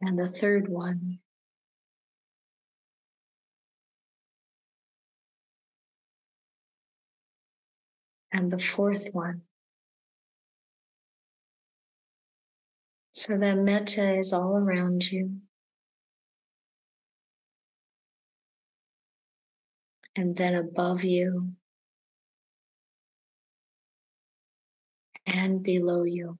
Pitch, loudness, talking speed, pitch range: 185 Hz, -28 LUFS, 50 wpm, 180-195 Hz